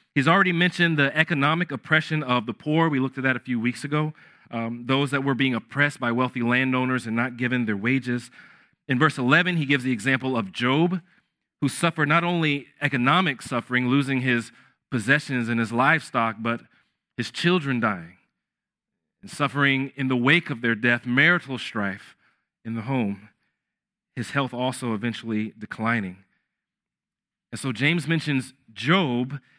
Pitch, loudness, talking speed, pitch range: 130 Hz, -23 LUFS, 160 wpm, 120-155 Hz